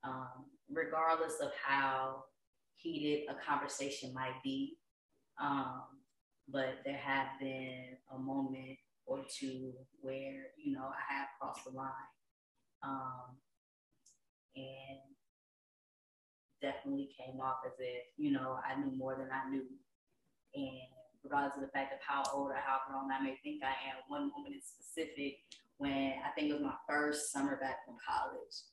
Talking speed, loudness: 150 wpm, -40 LUFS